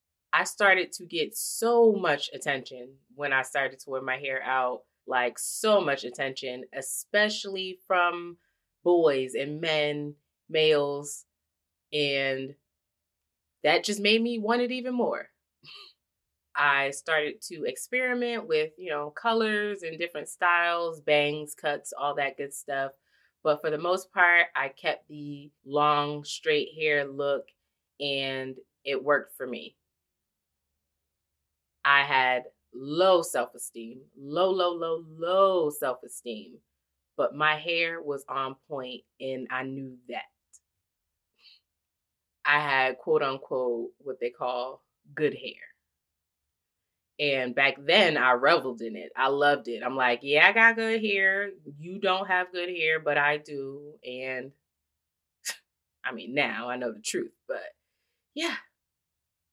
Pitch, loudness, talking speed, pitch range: 145 Hz, -27 LUFS, 135 wpm, 125-175 Hz